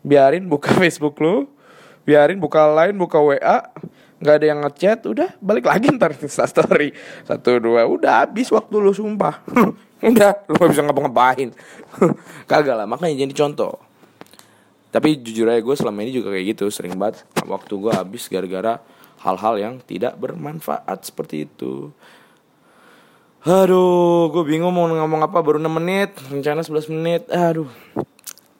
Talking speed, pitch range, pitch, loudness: 145 wpm, 135-175 Hz, 155 Hz, -18 LUFS